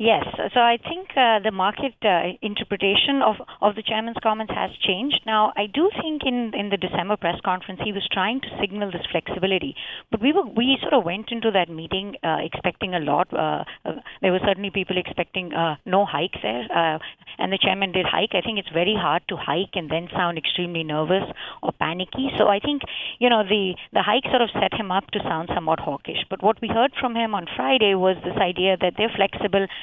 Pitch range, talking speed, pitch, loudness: 185-225 Hz, 215 wpm, 200 Hz, -22 LUFS